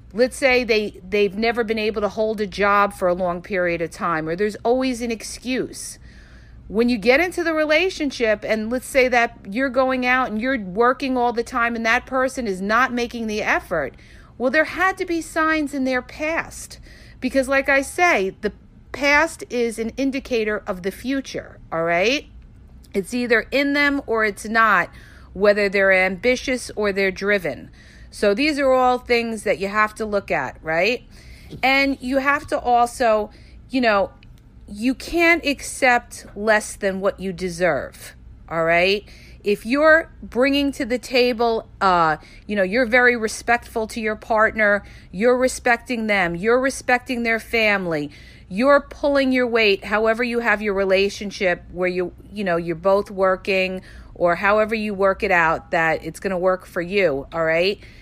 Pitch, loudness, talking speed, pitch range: 225 Hz, -20 LUFS, 175 wpm, 195-255 Hz